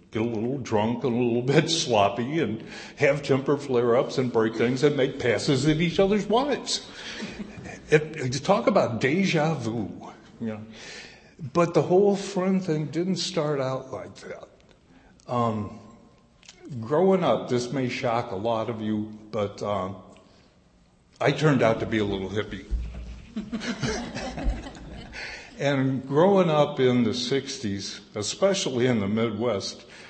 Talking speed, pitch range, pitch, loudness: 145 wpm, 115-160 Hz, 130 Hz, -25 LUFS